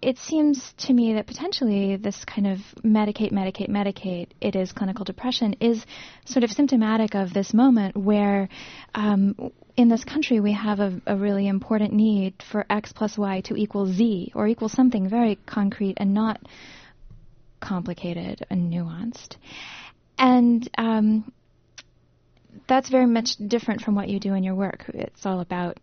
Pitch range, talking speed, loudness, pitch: 195-235 Hz, 160 wpm, -23 LUFS, 210 Hz